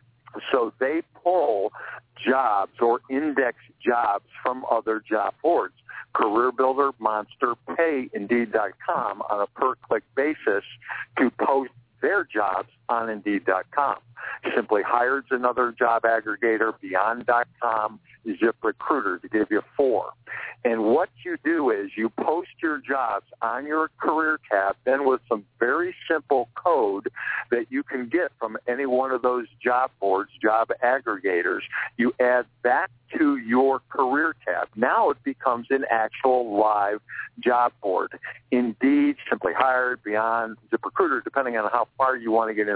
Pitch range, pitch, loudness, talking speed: 115-135 Hz, 125 Hz, -24 LUFS, 140 wpm